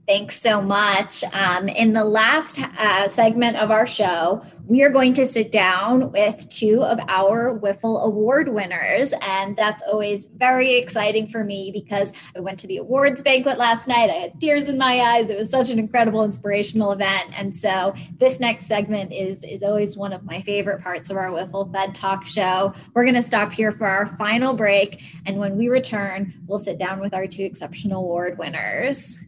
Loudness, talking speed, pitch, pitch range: -20 LUFS, 195 wpm, 205 Hz, 195-230 Hz